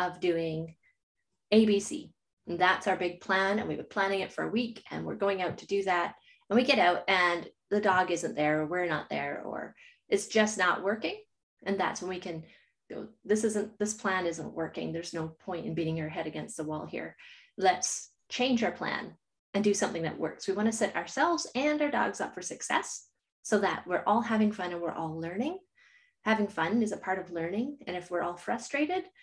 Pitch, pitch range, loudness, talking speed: 195 Hz, 175-230 Hz, -31 LUFS, 220 wpm